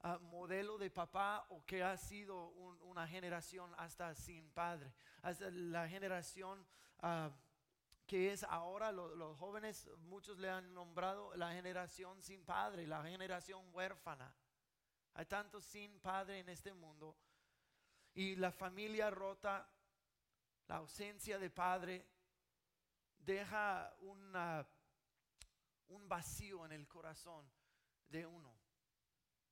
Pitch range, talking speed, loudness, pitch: 165-195 Hz, 120 wpm, -48 LUFS, 180 Hz